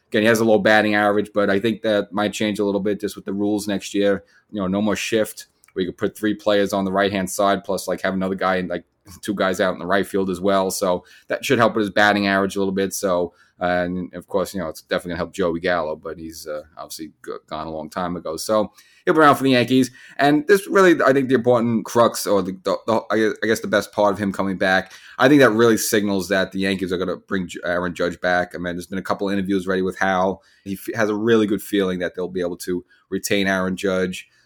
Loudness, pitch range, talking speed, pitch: -20 LUFS, 95-105 Hz, 270 wpm, 100 Hz